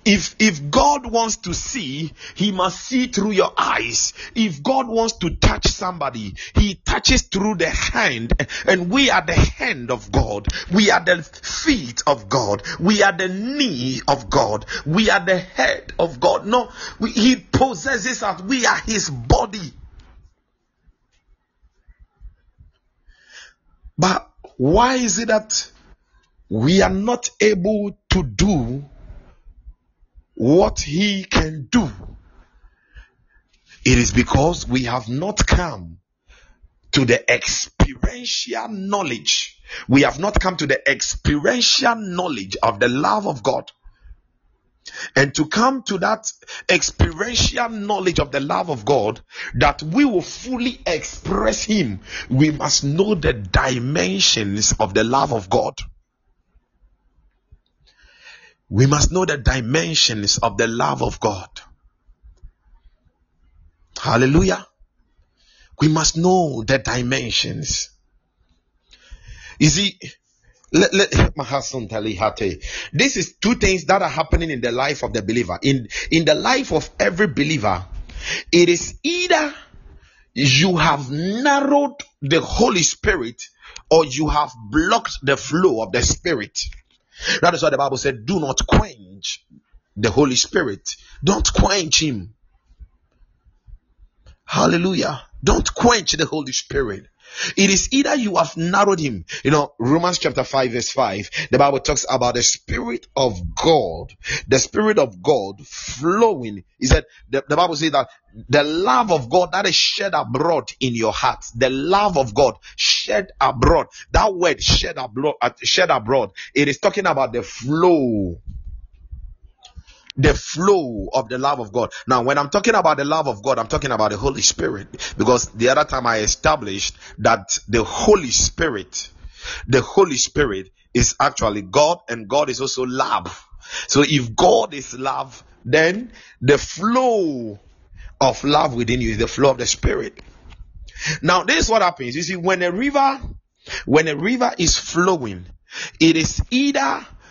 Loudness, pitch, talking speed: -18 LUFS, 140 Hz, 140 wpm